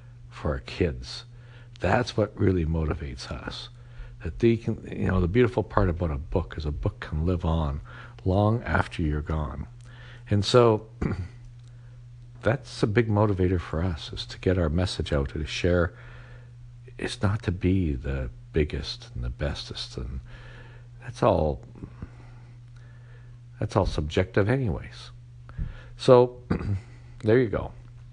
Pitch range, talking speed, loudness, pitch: 90-120 Hz, 140 wpm, -27 LUFS, 110 Hz